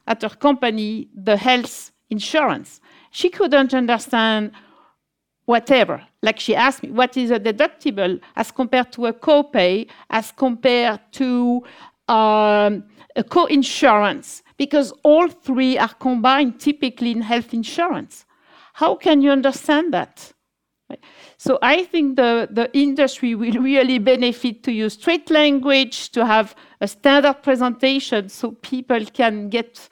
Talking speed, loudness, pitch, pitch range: 130 wpm, -18 LUFS, 255 Hz, 230-285 Hz